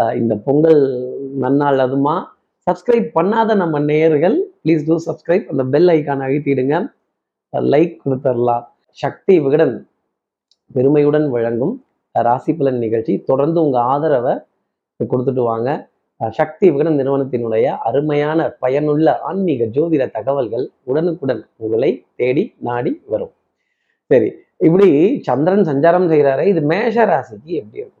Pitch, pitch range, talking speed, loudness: 145 Hz, 130-170 Hz, 110 wpm, -16 LUFS